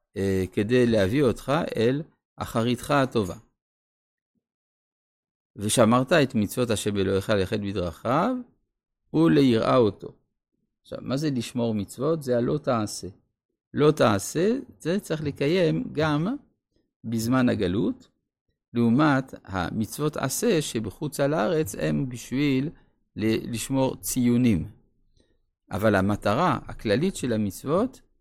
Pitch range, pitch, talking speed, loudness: 105-145 Hz, 120 Hz, 100 wpm, -25 LUFS